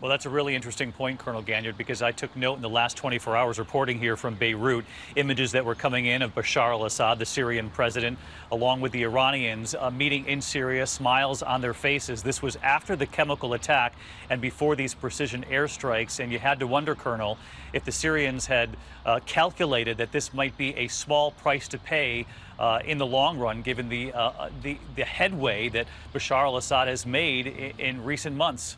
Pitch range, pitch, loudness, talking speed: 120-140 Hz, 130 Hz, -26 LUFS, 205 wpm